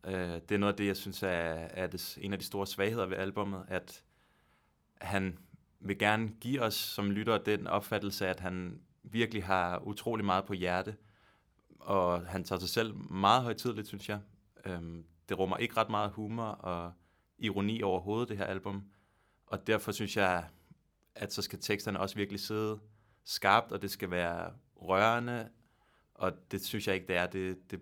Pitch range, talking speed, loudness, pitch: 95-105 Hz, 175 wpm, -34 LUFS, 100 Hz